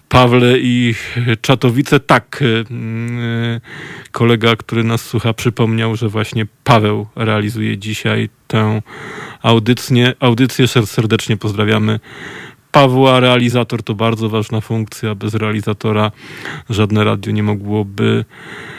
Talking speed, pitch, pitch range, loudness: 100 wpm, 115 Hz, 110-125 Hz, -14 LUFS